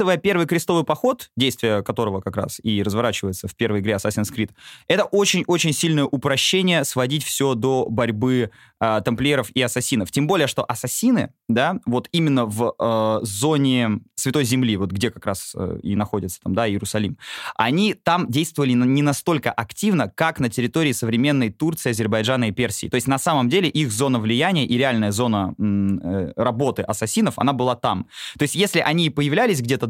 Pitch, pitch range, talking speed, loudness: 125 Hz, 110-145 Hz, 170 wpm, -21 LUFS